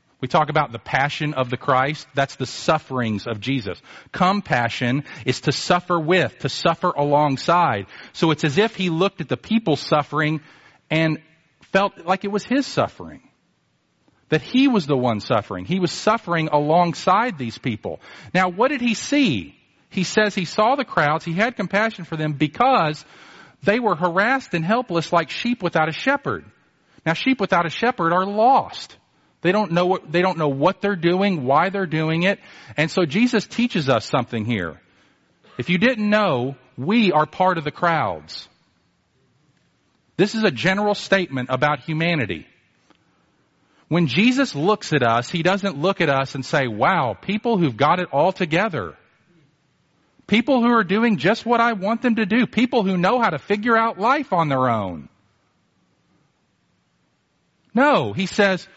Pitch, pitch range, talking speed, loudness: 170 Hz, 145-205 Hz, 170 wpm, -20 LUFS